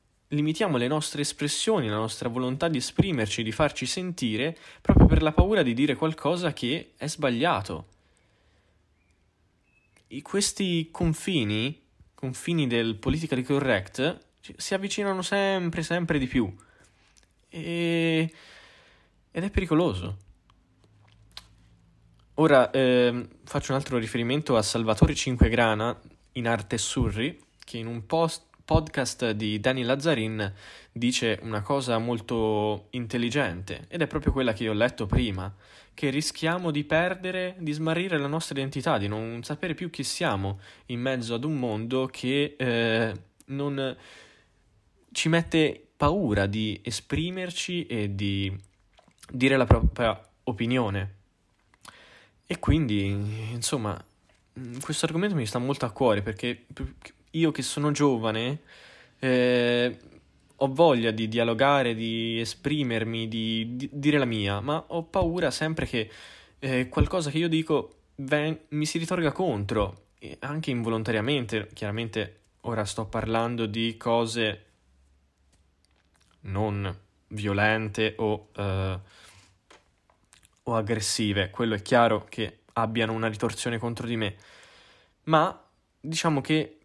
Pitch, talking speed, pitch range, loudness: 120 Hz, 120 wpm, 105-150 Hz, -27 LUFS